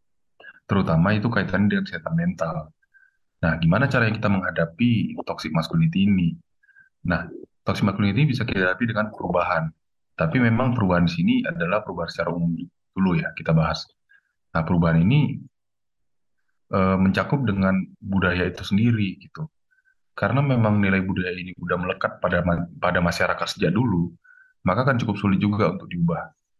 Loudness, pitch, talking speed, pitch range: -23 LUFS, 100 Hz, 145 wpm, 90-145 Hz